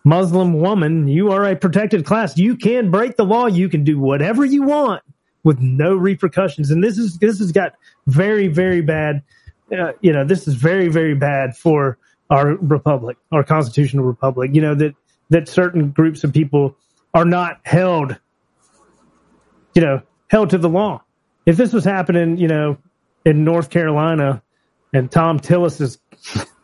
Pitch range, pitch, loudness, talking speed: 145-190 Hz, 165 Hz, -16 LUFS, 165 wpm